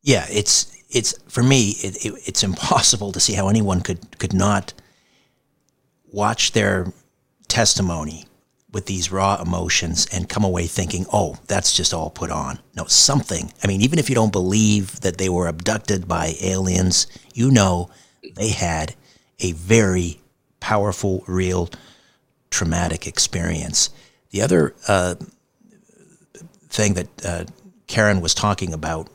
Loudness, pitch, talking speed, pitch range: -19 LUFS, 100 Hz, 140 wpm, 90-110 Hz